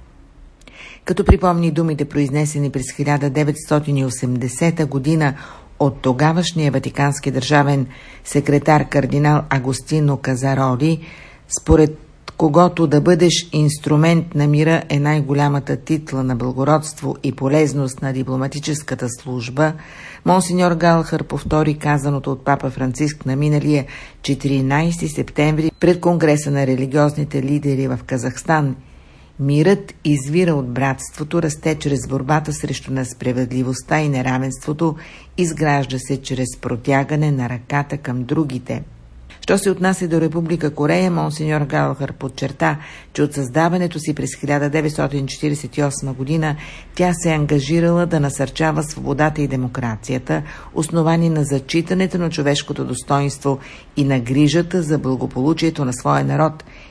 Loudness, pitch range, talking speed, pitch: -18 LUFS, 135-155 Hz, 115 wpm, 145 Hz